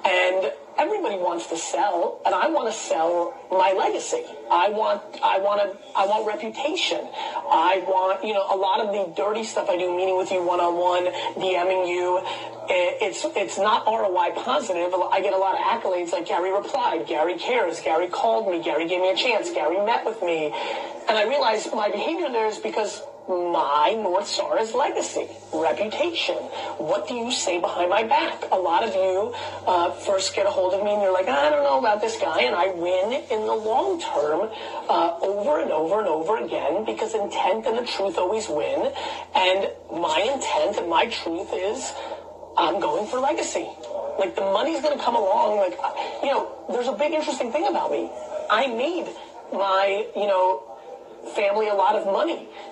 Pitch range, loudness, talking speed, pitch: 185-290 Hz, -23 LUFS, 185 wpm, 205 Hz